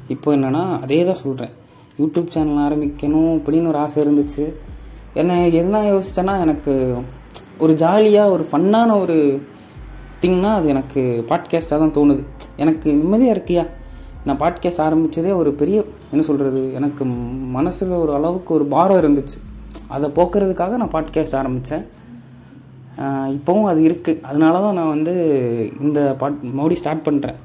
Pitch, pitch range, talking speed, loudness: 150 Hz, 135-170 Hz, 135 wpm, -18 LUFS